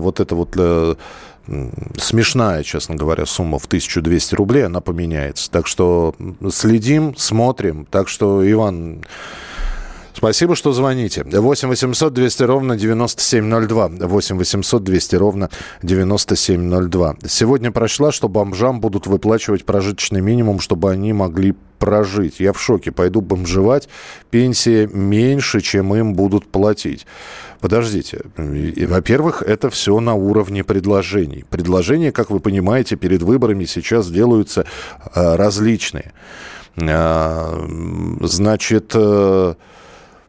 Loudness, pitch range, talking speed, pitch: -16 LUFS, 90-115 Hz, 110 wpm, 100 Hz